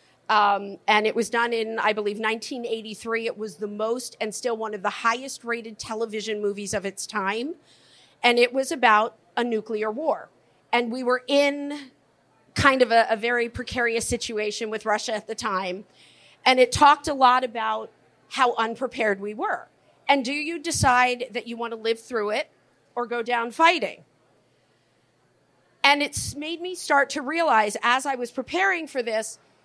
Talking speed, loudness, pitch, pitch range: 175 wpm, -24 LUFS, 235 Hz, 220-260 Hz